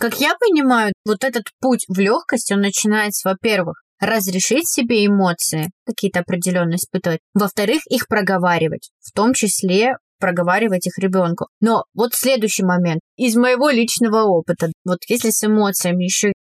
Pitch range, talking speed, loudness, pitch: 185-235 Hz, 140 wpm, -17 LUFS, 205 Hz